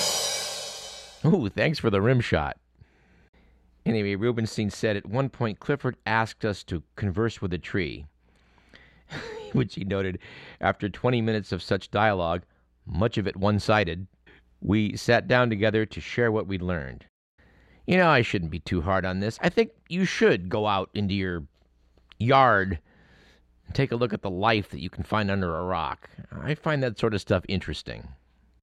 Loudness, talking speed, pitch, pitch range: -26 LUFS, 170 wpm, 100 Hz, 85-115 Hz